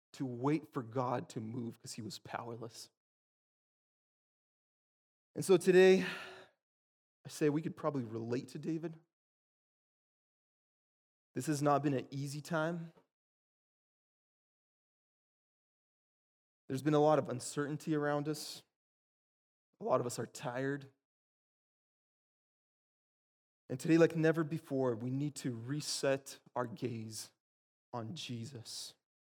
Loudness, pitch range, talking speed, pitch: -35 LUFS, 120-155 Hz, 115 wpm, 135 Hz